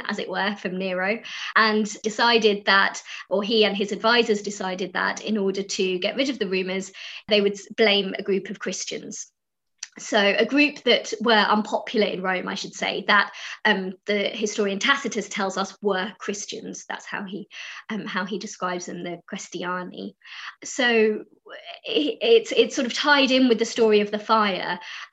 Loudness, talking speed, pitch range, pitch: -22 LUFS, 175 wpm, 195-225 Hz, 210 Hz